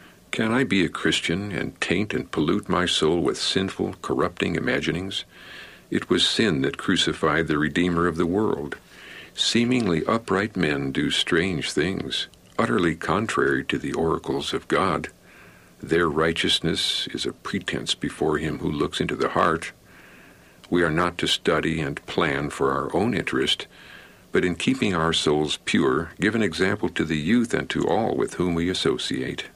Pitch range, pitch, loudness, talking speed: 75-95 Hz, 85 Hz, -23 LUFS, 160 wpm